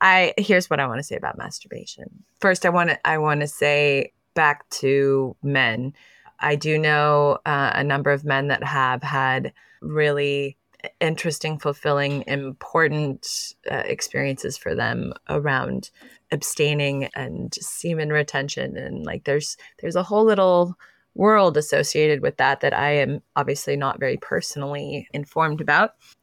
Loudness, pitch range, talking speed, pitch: -22 LUFS, 140-160 Hz, 145 wpm, 145 Hz